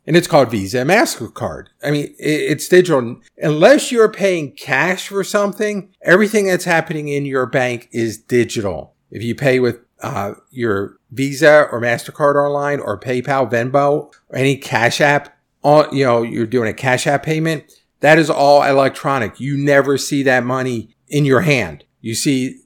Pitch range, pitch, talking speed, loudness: 125-150 Hz, 140 Hz, 170 wpm, -16 LUFS